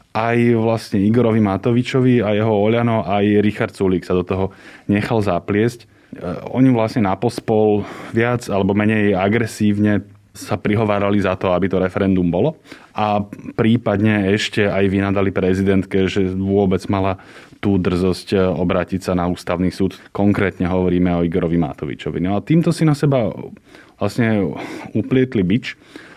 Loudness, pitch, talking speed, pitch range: -18 LUFS, 100 Hz, 140 wpm, 95-110 Hz